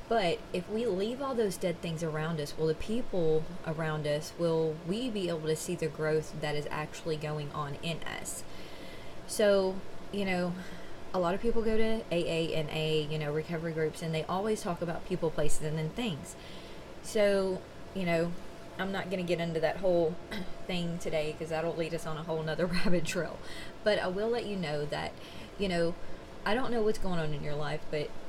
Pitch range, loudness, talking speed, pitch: 155-190 Hz, -33 LUFS, 210 wpm, 170 Hz